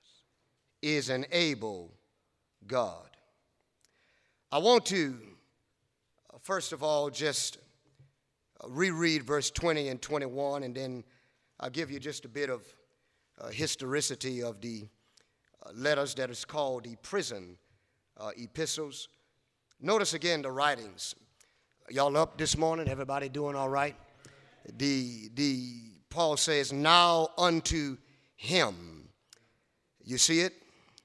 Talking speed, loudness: 120 wpm, -31 LUFS